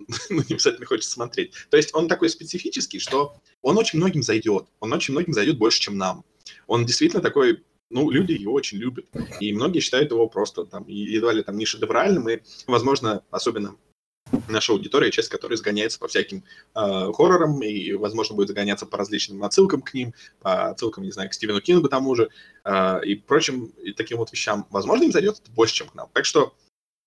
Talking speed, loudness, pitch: 195 wpm, -22 LUFS, 140 Hz